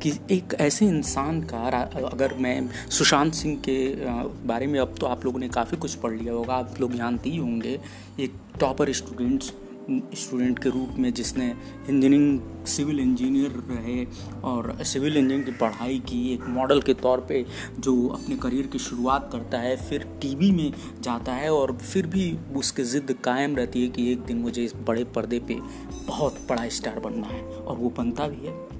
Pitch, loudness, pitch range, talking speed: 130 Hz, -26 LUFS, 120-145 Hz, 185 wpm